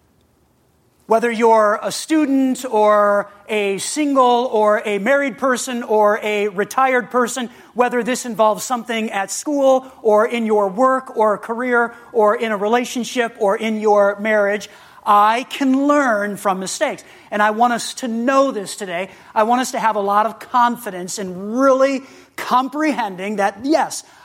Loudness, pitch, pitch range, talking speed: -17 LUFS, 225 Hz, 210-255 Hz, 155 wpm